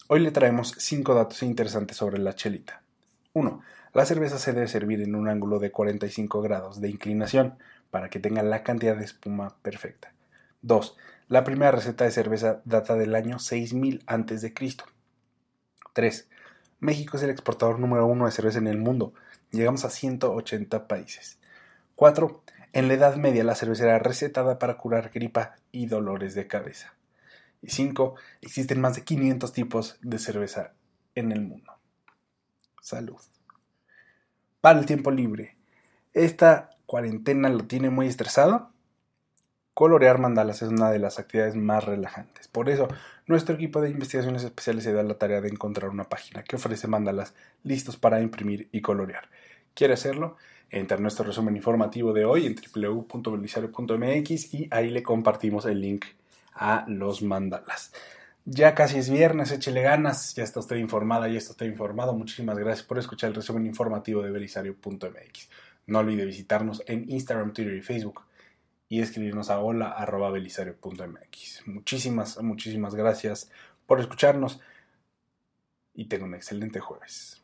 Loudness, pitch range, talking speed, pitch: -26 LUFS, 105-130 Hz, 150 wpm, 115 Hz